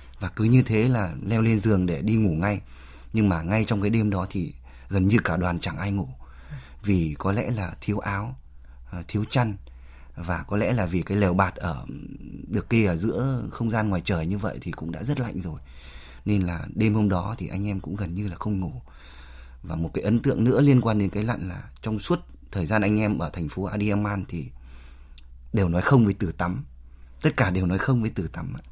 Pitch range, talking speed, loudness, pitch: 80-110 Hz, 230 wpm, -25 LUFS, 95 Hz